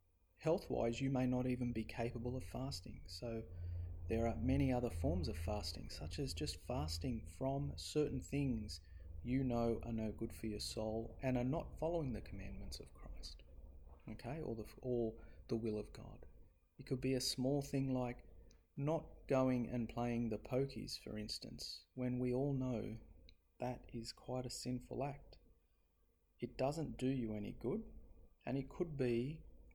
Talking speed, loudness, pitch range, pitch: 165 wpm, -42 LUFS, 85-130 Hz, 115 Hz